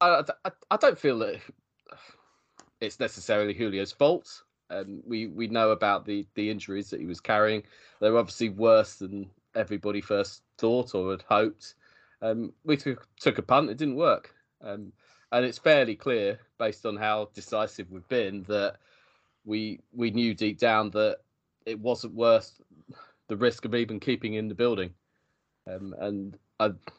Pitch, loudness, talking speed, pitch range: 110 Hz, -28 LUFS, 165 wpm, 100-115 Hz